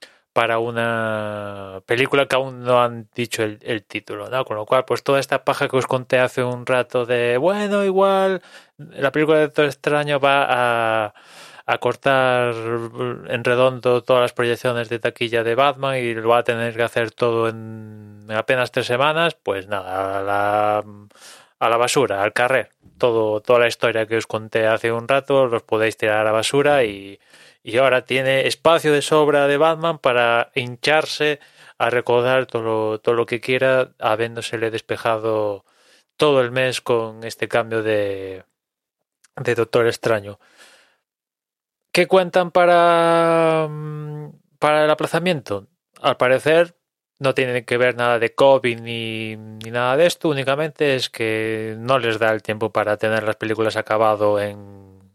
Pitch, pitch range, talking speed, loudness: 120 Hz, 110-140 Hz, 160 wpm, -19 LUFS